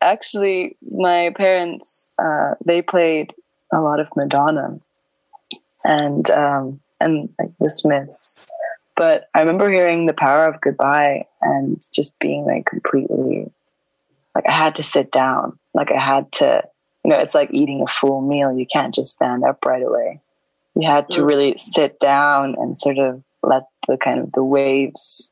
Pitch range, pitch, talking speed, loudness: 140-185 Hz, 150 Hz, 160 wpm, -18 LUFS